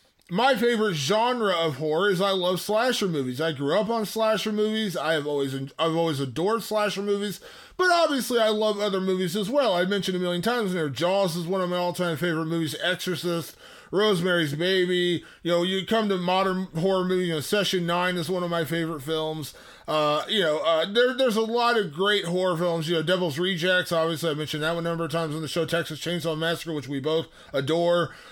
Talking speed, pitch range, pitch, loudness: 215 wpm, 165-205 Hz, 180 Hz, -25 LUFS